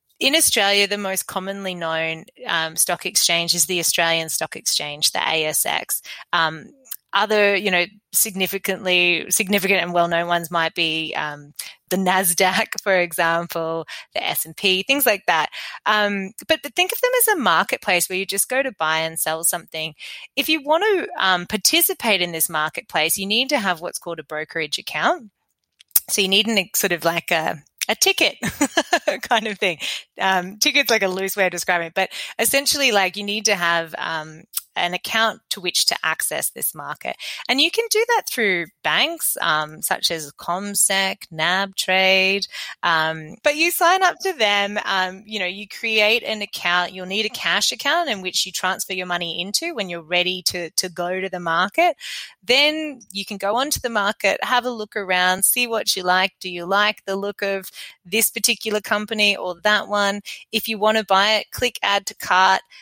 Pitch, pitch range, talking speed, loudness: 195 Hz, 175-220 Hz, 190 wpm, -19 LUFS